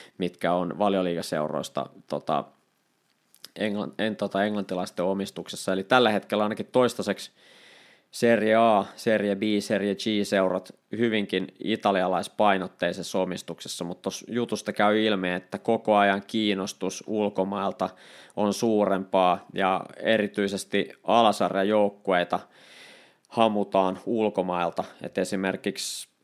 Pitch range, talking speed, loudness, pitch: 95-105 Hz, 100 wpm, -26 LUFS, 100 Hz